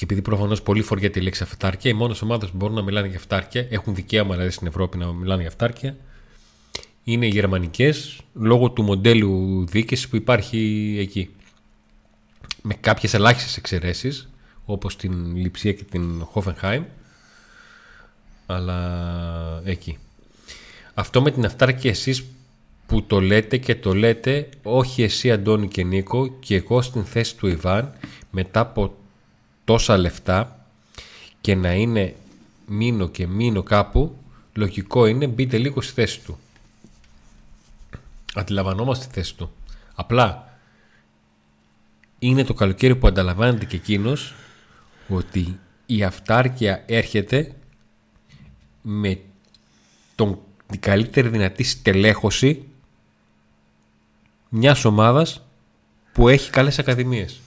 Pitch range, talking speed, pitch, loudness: 95-125 Hz, 120 wpm, 105 Hz, -21 LUFS